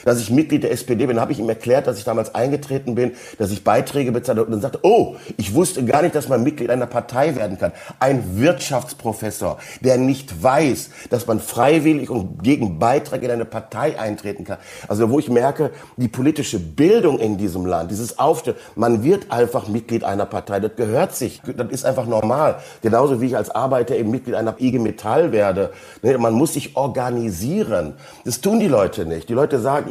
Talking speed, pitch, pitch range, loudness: 195 wpm, 120 Hz, 110-135 Hz, -19 LUFS